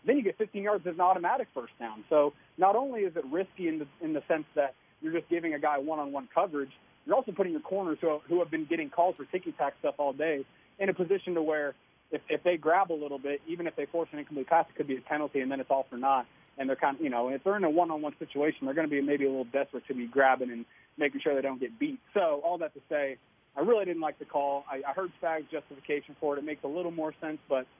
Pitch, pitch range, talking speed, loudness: 155 Hz, 140-175 Hz, 290 wpm, -31 LUFS